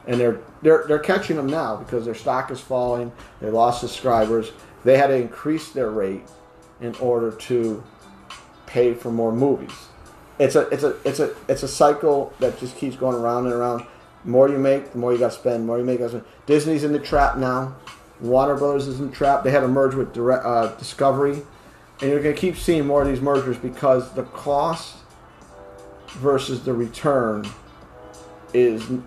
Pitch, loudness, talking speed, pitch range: 130 Hz, -21 LUFS, 195 wpm, 120-140 Hz